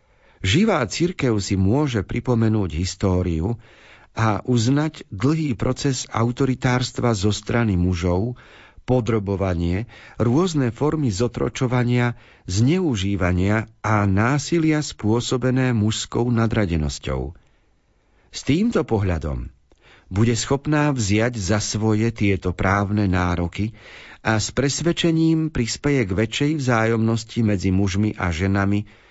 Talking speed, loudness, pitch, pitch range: 95 wpm, -21 LUFS, 110 Hz, 100-125 Hz